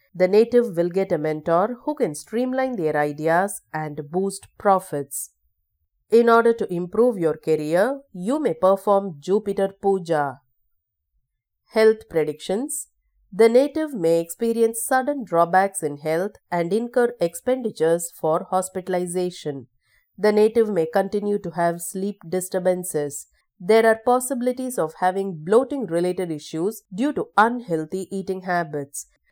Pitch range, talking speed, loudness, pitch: 160-225 Hz, 125 wpm, -22 LUFS, 185 Hz